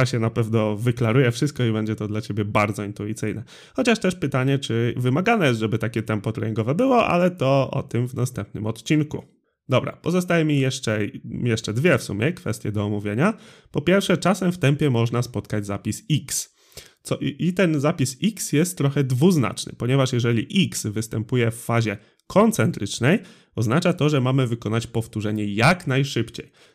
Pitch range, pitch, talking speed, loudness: 110-155 Hz, 125 Hz, 165 wpm, -22 LUFS